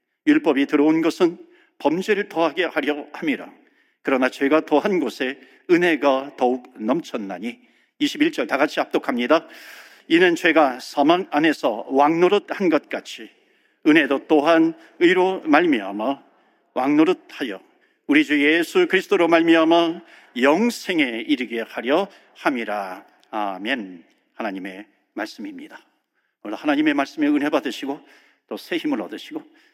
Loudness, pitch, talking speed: -20 LUFS, 265 Hz, 270 characters per minute